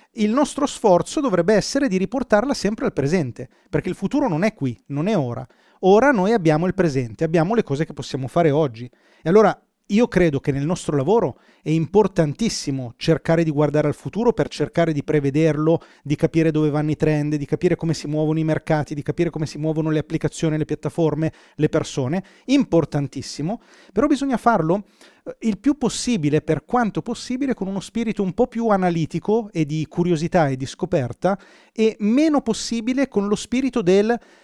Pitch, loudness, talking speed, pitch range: 170 Hz, -21 LUFS, 180 wpm, 150-215 Hz